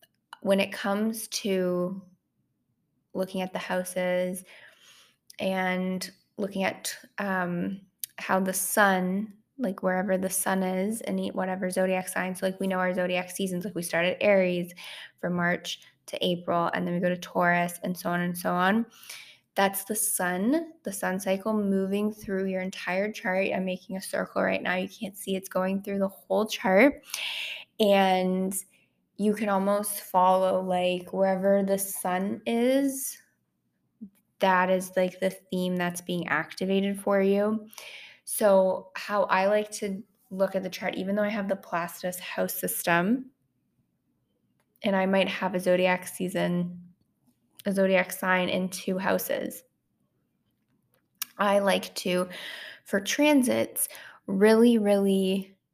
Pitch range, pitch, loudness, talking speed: 185-200 Hz, 190 Hz, -27 LUFS, 145 wpm